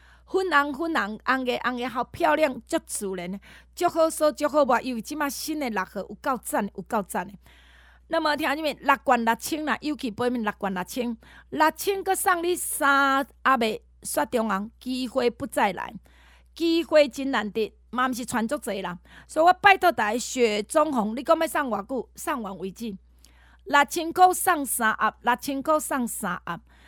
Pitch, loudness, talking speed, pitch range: 260 Hz, -25 LUFS, 250 characters per minute, 220-305 Hz